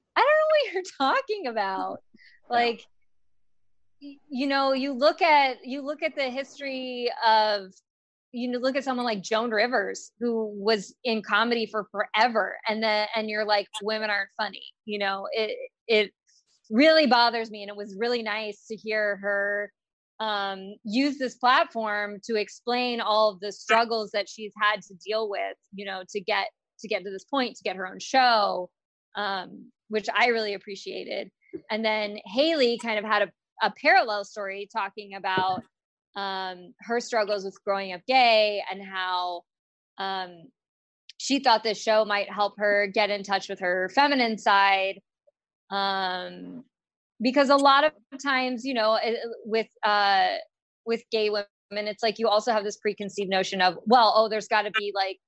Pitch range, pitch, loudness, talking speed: 200-245 Hz, 215 Hz, -25 LUFS, 170 wpm